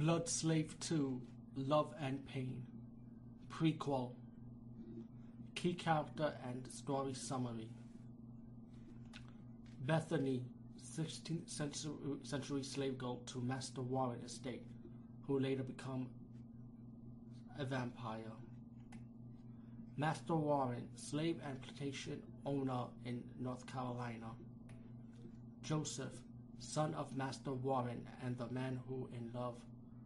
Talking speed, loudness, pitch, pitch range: 95 wpm, -43 LUFS, 120 Hz, 120-135 Hz